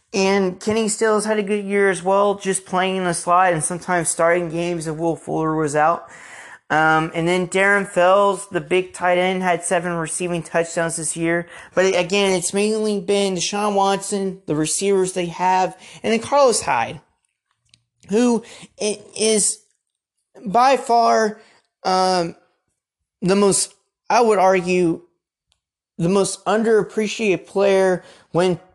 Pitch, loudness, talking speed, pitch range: 185 Hz, -19 LUFS, 140 wpm, 175-200 Hz